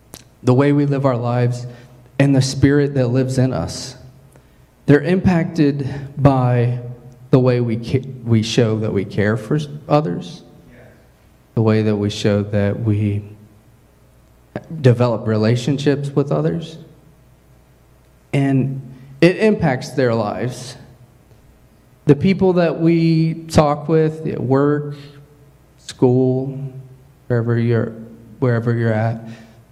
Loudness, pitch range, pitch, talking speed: -17 LUFS, 115-145 Hz, 130 Hz, 115 wpm